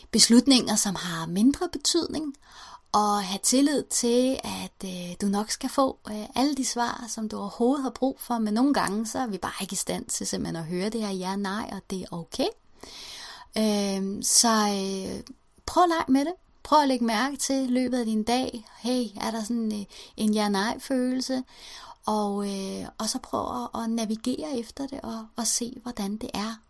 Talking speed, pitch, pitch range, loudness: 195 wpm, 235 Hz, 205-260 Hz, -26 LUFS